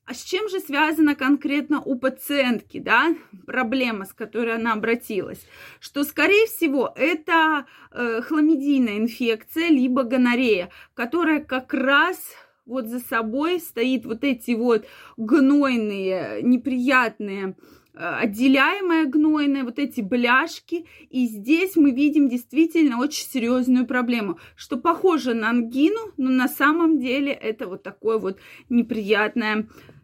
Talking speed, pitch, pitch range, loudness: 125 wpm, 260 Hz, 235-305 Hz, -21 LUFS